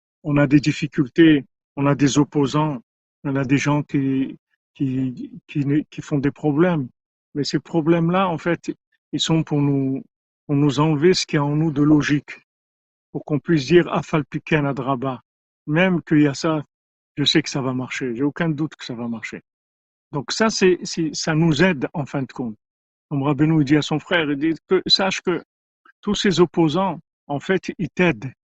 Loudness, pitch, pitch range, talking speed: -20 LUFS, 150 Hz, 140-165 Hz, 195 wpm